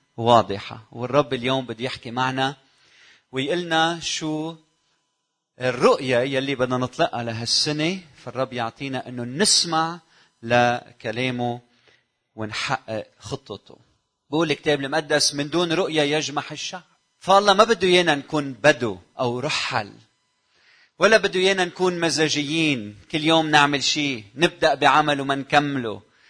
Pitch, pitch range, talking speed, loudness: 145 Hz, 125-160 Hz, 110 wpm, -21 LUFS